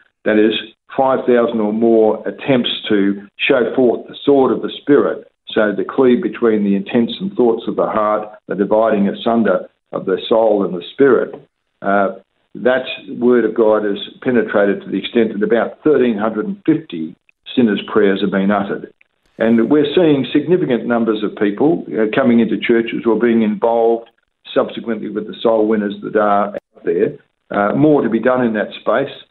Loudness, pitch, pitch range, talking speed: -16 LUFS, 115 Hz, 105-120 Hz, 170 wpm